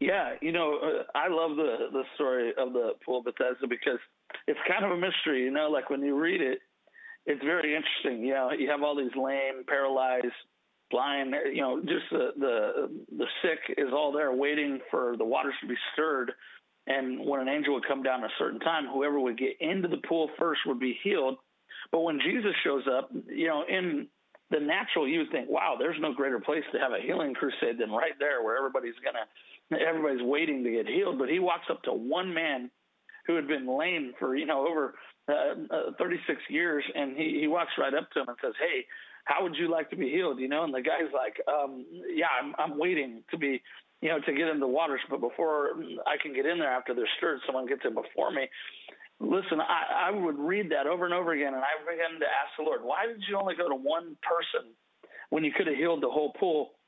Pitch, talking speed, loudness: 165 Hz, 230 wpm, -30 LUFS